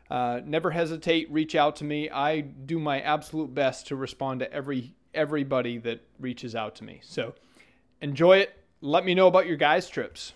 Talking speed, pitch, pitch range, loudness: 185 wpm, 145 Hz, 130-160 Hz, -26 LUFS